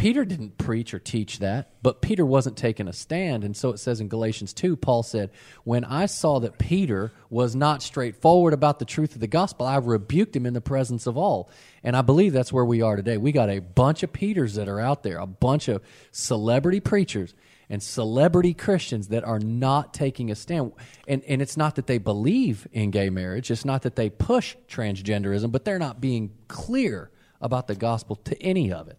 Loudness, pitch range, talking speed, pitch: -24 LUFS, 110-150 Hz, 215 wpm, 125 Hz